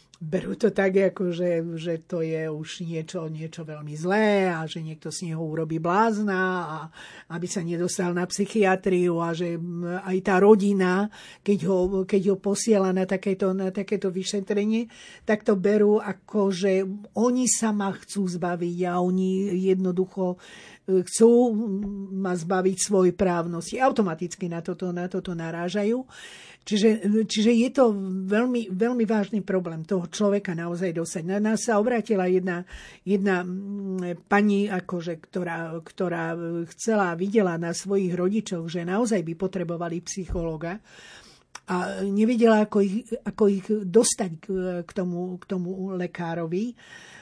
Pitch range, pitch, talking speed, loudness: 175-205 Hz, 190 Hz, 135 wpm, -25 LUFS